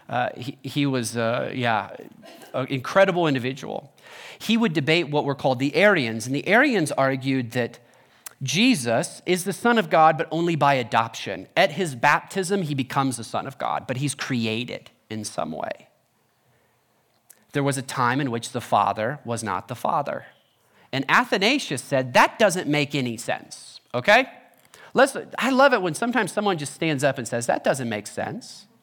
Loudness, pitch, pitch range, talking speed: -23 LUFS, 140 Hz, 125-185 Hz, 175 wpm